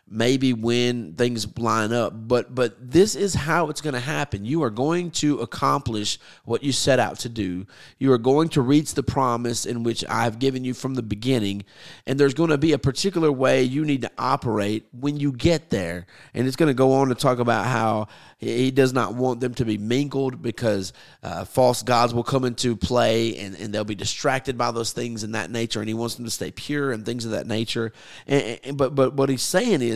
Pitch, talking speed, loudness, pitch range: 125 Hz, 230 wpm, -23 LUFS, 115-135 Hz